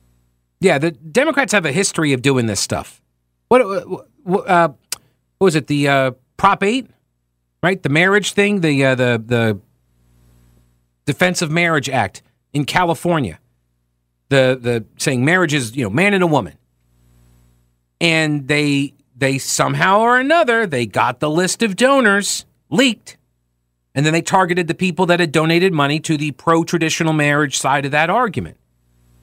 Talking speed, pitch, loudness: 155 wpm, 145 Hz, -16 LUFS